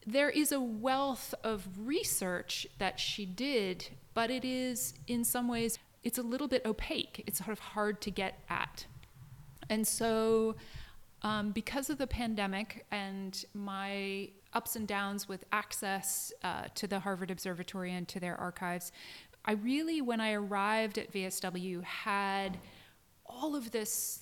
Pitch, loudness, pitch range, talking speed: 210 Hz, -36 LUFS, 190-235 Hz, 150 wpm